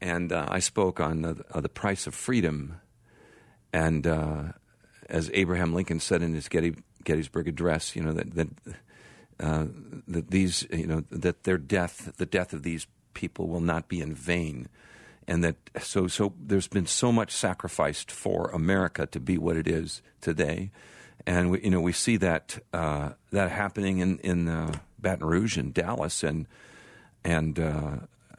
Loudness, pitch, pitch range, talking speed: -29 LUFS, 85 Hz, 80-95 Hz, 170 wpm